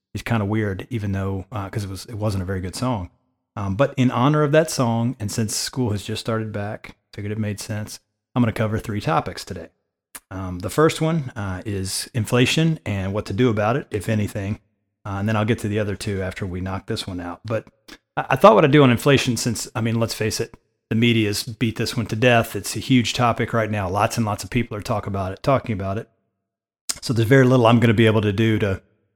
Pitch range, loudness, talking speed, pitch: 105-120 Hz, -21 LUFS, 255 wpm, 110 Hz